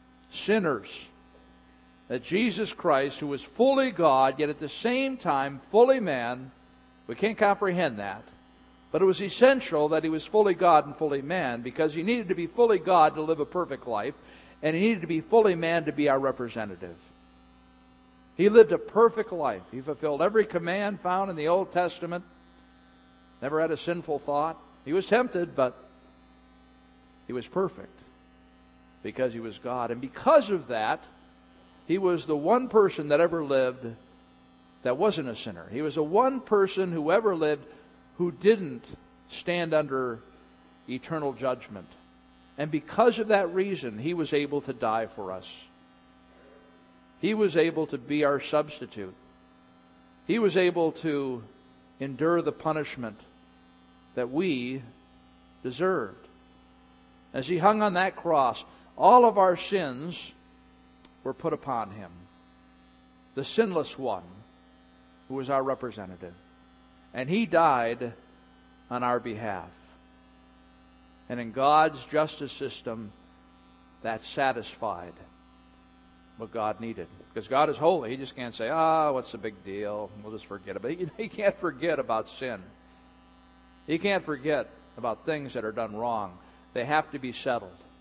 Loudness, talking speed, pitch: -27 LUFS, 150 wpm, 130 Hz